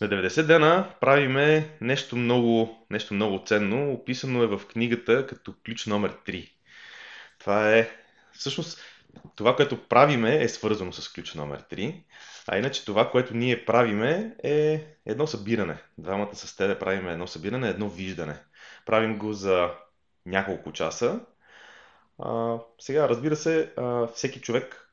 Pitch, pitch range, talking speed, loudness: 115 Hz, 100-135 Hz, 140 wpm, -25 LUFS